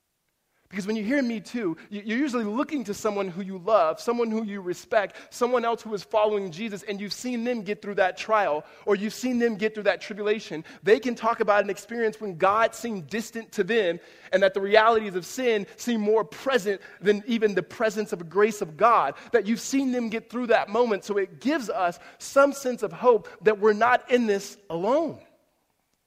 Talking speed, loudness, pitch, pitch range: 210 wpm, -25 LUFS, 215 Hz, 200-235 Hz